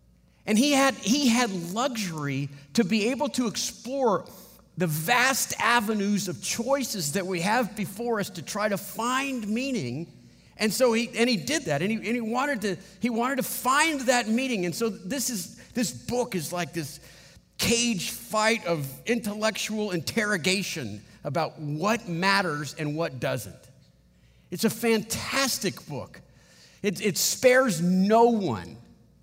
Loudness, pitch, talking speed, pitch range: -26 LUFS, 210 Hz, 150 wpm, 170-235 Hz